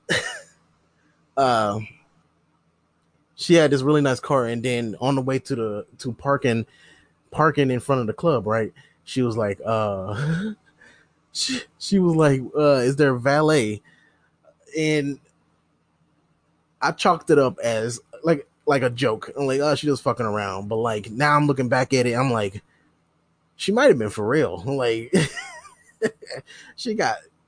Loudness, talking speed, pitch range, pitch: -22 LUFS, 160 wpm, 115-150 Hz, 130 Hz